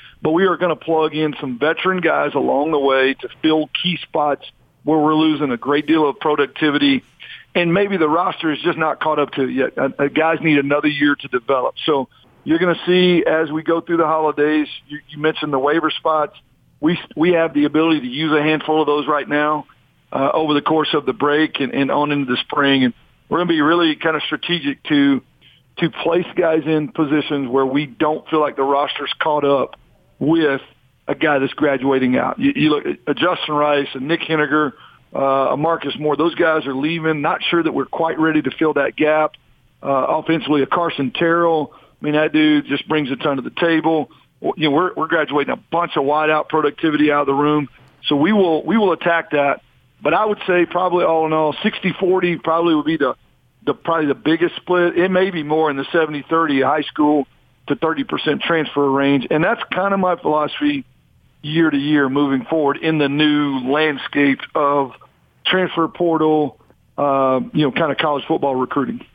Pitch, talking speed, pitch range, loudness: 150 Hz, 205 wpm, 145-160 Hz, -18 LUFS